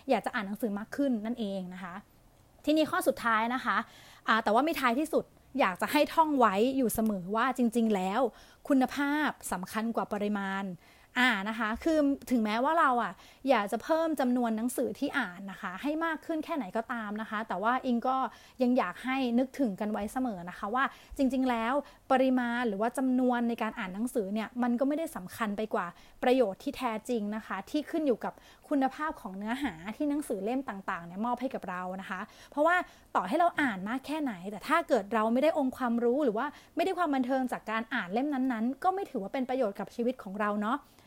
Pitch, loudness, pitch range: 245 Hz, -31 LUFS, 220-275 Hz